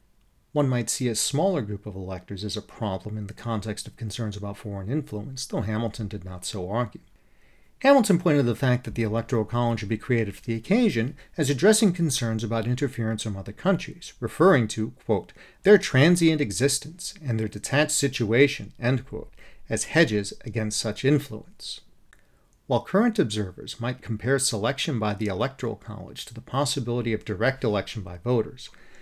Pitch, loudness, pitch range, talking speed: 115 Hz, -25 LUFS, 105-140 Hz, 170 wpm